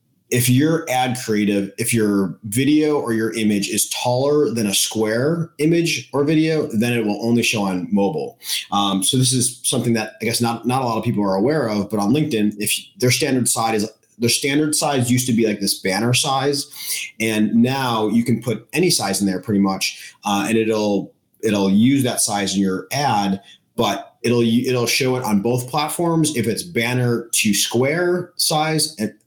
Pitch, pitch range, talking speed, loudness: 115 Hz, 105-135 Hz, 195 wpm, -19 LUFS